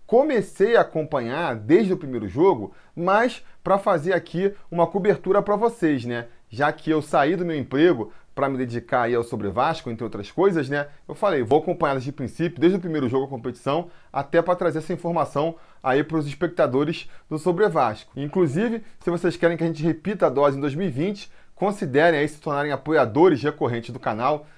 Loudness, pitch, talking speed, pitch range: -23 LUFS, 155 Hz, 190 wpm, 135-180 Hz